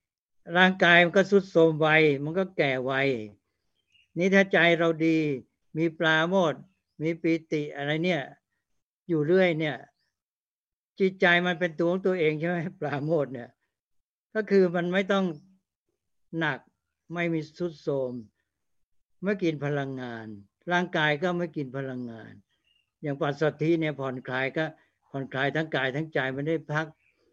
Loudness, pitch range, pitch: -26 LUFS, 135-175 Hz, 155 Hz